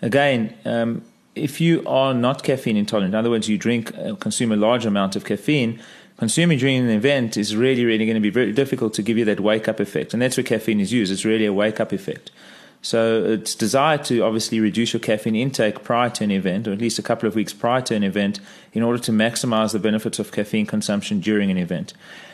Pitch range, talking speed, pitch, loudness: 110-125 Hz, 235 wpm, 115 Hz, -20 LUFS